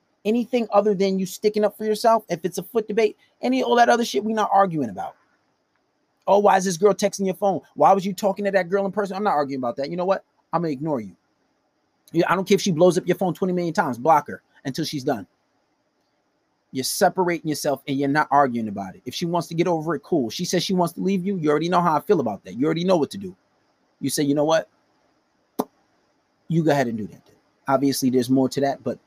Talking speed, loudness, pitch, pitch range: 255 wpm, -22 LUFS, 180 Hz, 150-200 Hz